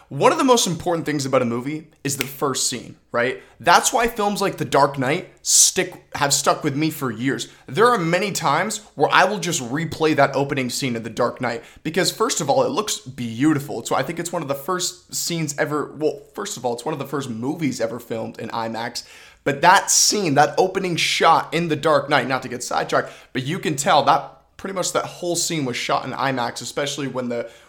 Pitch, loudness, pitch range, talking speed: 150 Hz, -20 LUFS, 130-170 Hz, 225 wpm